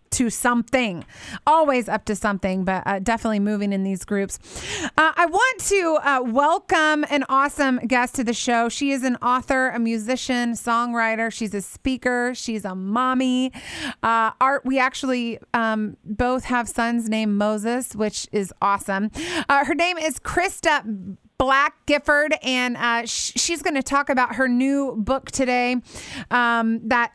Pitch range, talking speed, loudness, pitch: 225-275 Hz, 160 wpm, -21 LUFS, 245 Hz